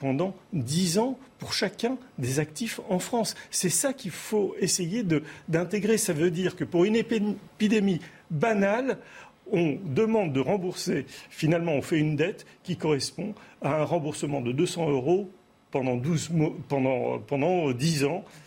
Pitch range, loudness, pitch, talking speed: 150-210 Hz, -27 LUFS, 175 Hz, 155 wpm